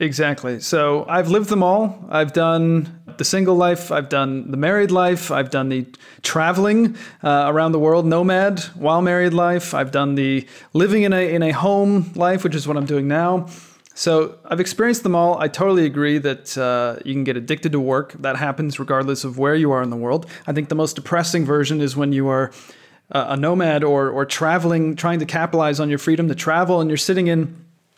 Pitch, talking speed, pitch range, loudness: 160 Hz, 210 wpm, 140-175 Hz, -19 LUFS